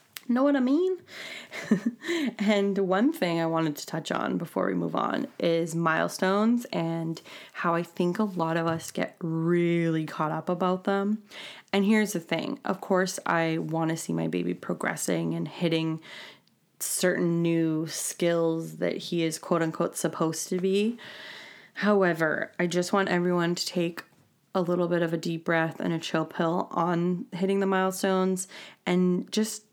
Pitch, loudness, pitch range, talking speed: 175 Hz, -27 LUFS, 165-195 Hz, 165 wpm